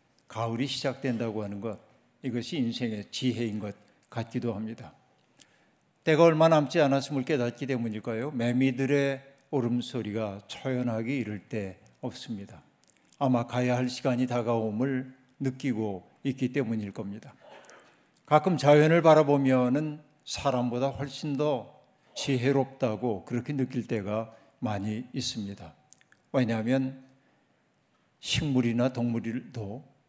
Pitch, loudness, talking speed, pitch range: 125 Hz, -28 LUFS, 265 characters per minute, 115-135 Hz